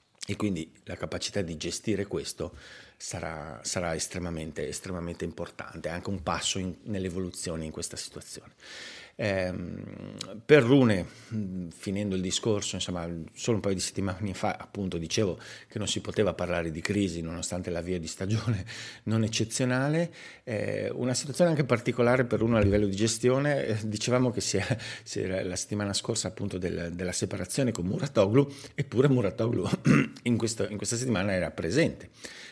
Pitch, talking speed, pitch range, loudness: 100 Hz, 160 wpm, 90-115 Hz, -29 LUFS